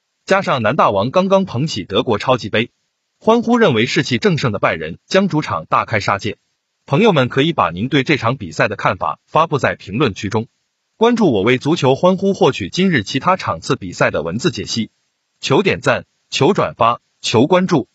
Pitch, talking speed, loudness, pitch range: 135 Hz, 290 characters per minute, -16 LUFS, 115-185 Hz